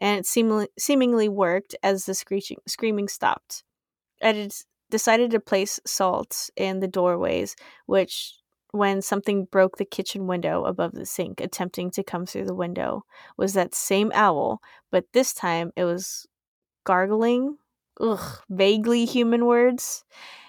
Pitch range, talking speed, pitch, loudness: 190-225 Hz, 145 wpm, 200 Hz, -24 LUFS